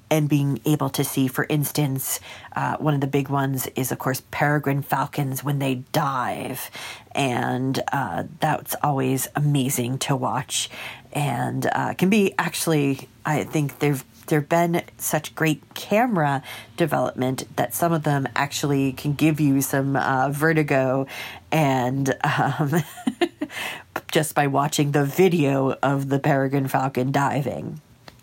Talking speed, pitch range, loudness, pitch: 140 wpm, 130-150 Hz, -23 LUFS, 140 Hz